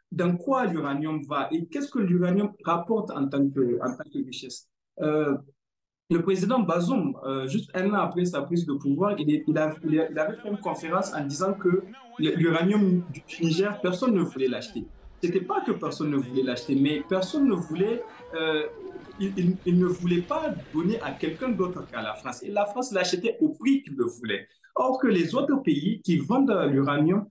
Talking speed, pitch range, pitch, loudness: 185 wpm, 150-210 Hz, 180 Hz, -26 LUFS